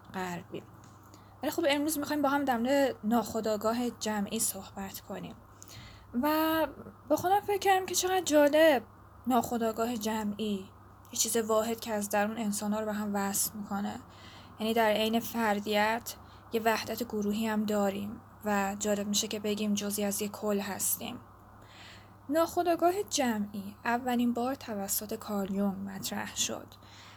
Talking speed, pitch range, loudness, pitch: 135 wpm, 205-245 Hz, -30 LUFS, 220 Hz